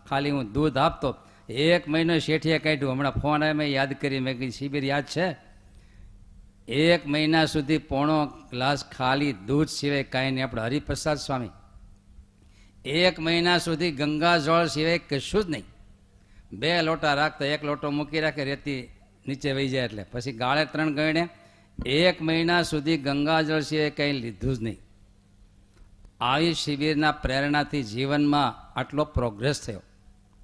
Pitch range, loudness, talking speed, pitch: 115-155 Hz, -25 LUFS, 145 wpm, 140 Hz